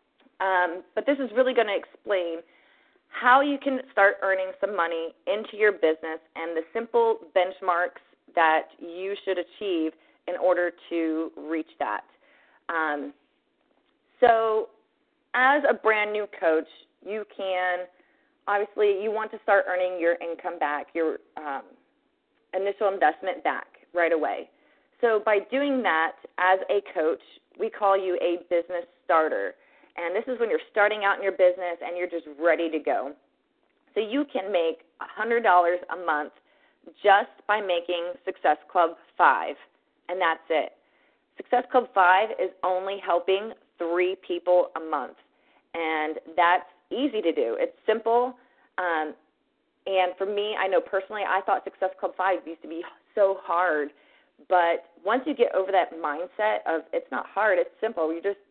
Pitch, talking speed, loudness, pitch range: 190 Hz, 155 wpm, -26 LUFS, 170-230 Hz